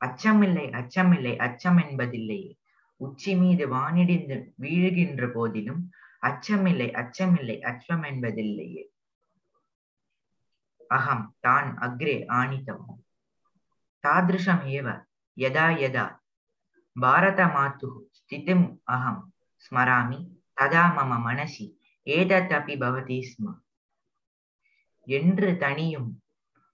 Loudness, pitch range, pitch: -25 LUFS, 125-180 Hz, 145 Hz